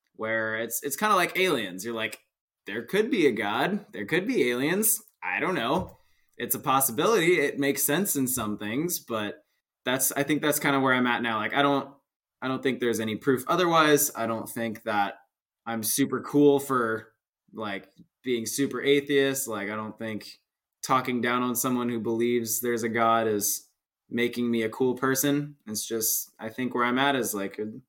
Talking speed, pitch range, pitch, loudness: 195 wpm, 110-140 Hz, 120 Hz, -26 LUFS